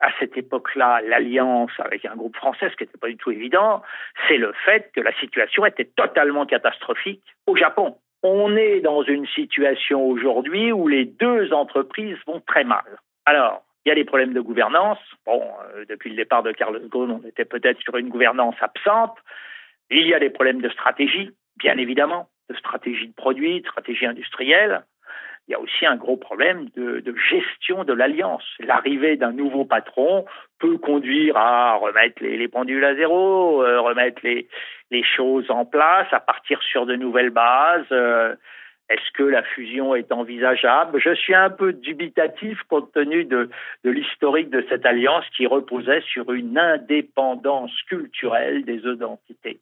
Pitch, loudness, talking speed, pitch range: 135 Hz, -20 LUFS, 170 wpm, 125-185 Hz